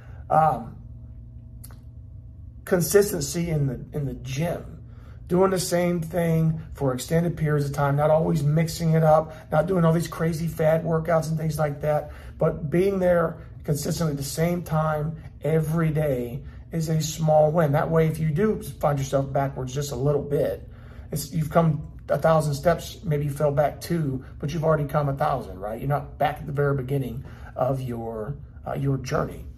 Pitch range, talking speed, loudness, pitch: 140-160 Hz, 180 wpm, -24 LUFS, 155 Hz